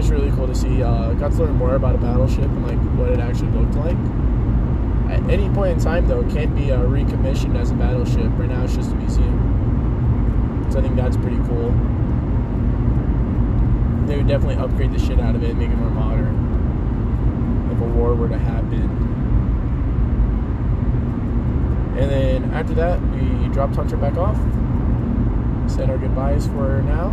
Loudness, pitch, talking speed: -20 LUFS, 65 Hz, 175 wpm